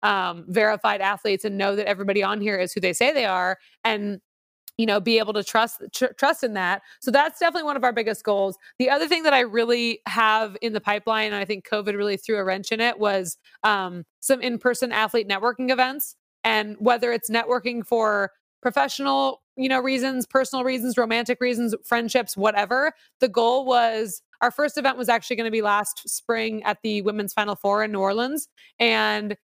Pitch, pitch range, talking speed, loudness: 225 Hz, 205-250 Hz, 200 wpm, -23 LUFS